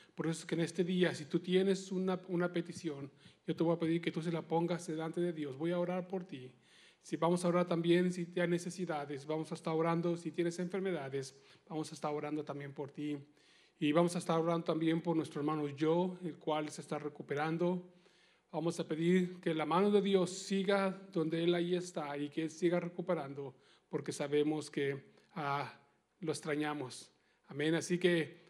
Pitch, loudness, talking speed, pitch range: 165 Hz, -36 LUFS, 200 wpm, 155-175 Hz